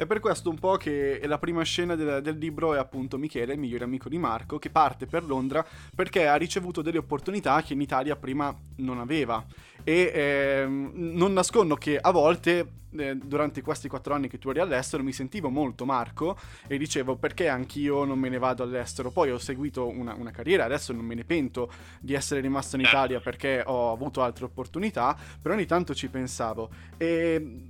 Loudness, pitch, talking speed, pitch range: -28 LUFS, 140 Hz, 195 wpm, 125-155 Hz